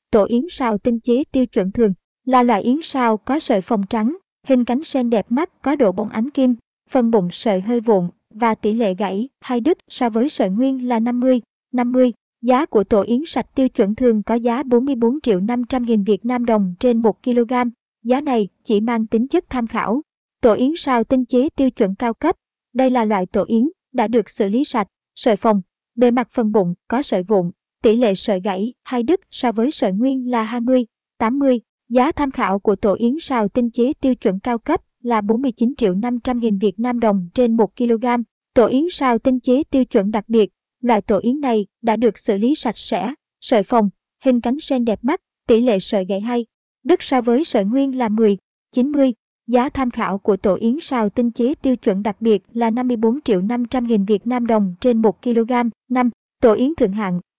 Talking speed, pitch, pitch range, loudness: 215 wpm, 240 Hz, 220-255 Hz, -18 LUFS